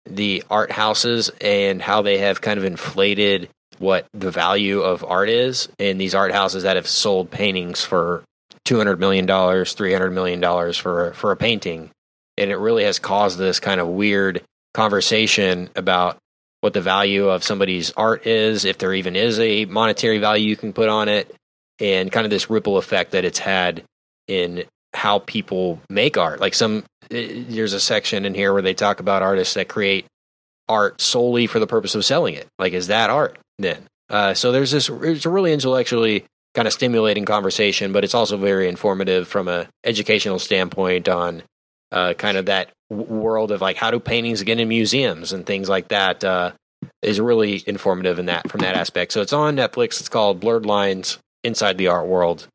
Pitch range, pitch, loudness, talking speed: 95-110 Hz, 100 Hz, -19 LUFS, 190 wpm